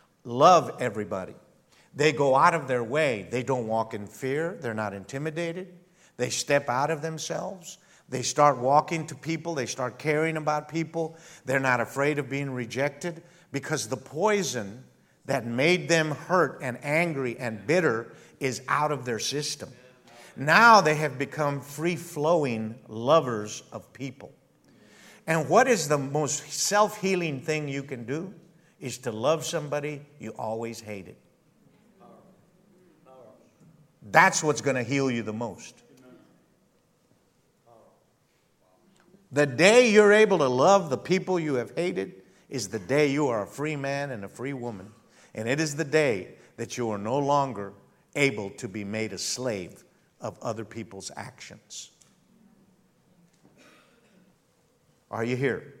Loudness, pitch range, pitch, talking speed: -26 LUFS, 125-165 Hz, 145 Hz, 145 wpm